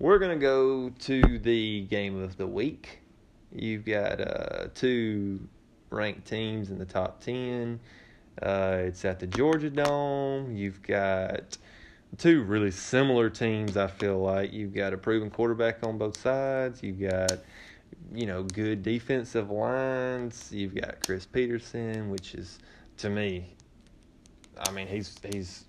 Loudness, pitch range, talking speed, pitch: -29 LUFS, 95-120 Hz, 140 wpm, 110 Hz